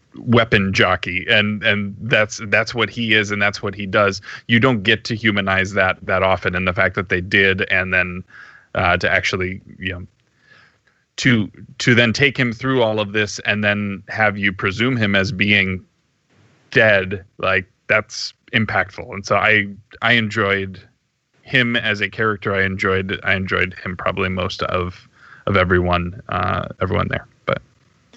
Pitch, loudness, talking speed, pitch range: 100 Hz, -18 LUFS, 165 wpm, 95-110 Hz